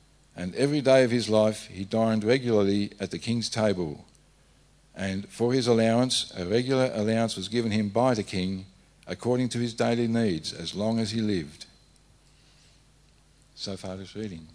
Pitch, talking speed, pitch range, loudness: 110 Hz, 165 wpm, 100-120 Hz, -26 LUFS